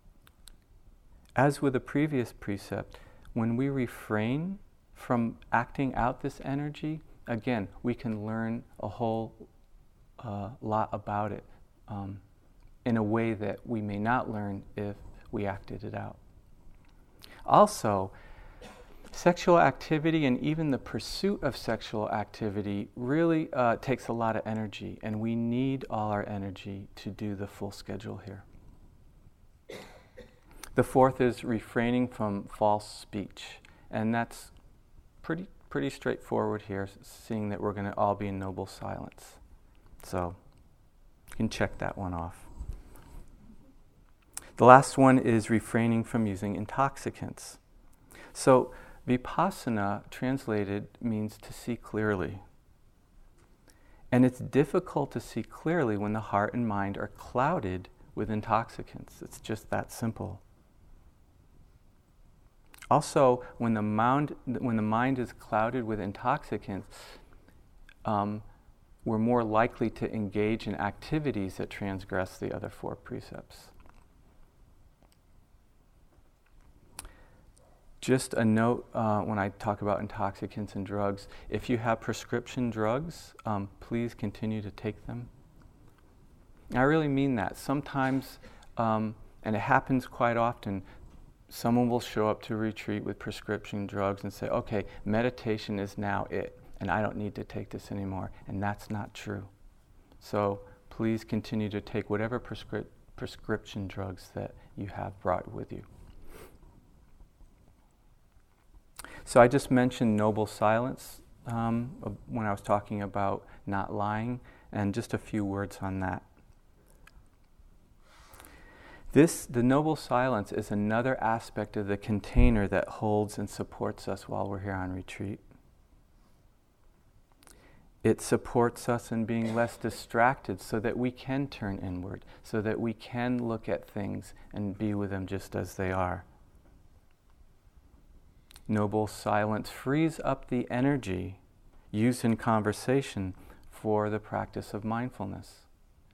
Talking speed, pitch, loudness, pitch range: 130 wpm, 105 Hz, -31 LUFS, 100-120 Hz